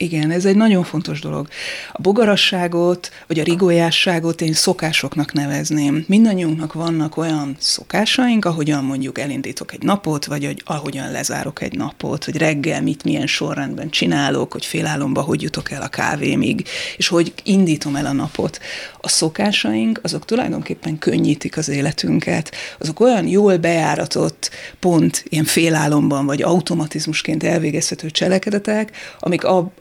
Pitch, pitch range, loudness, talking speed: 165 Hz, 150-185 Hz, -18 LUFS, 135 wpm